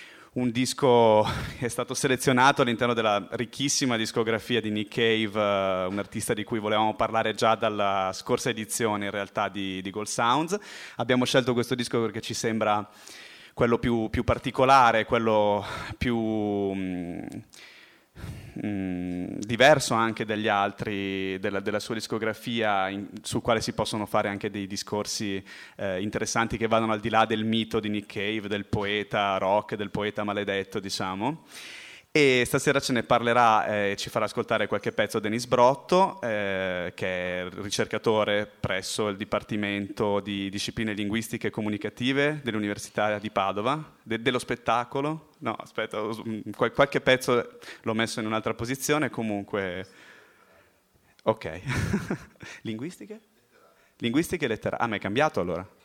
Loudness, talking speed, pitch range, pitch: -26 LUFS, 140 wpm, 105-120 Hz, 110 Hz